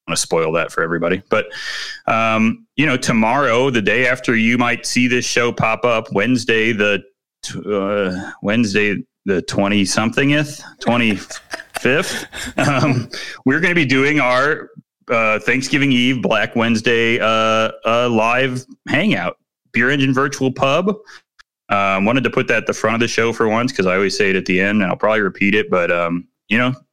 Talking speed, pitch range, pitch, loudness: 180 wpm, 105-130 Hz, 120 Hz, -16 LUFS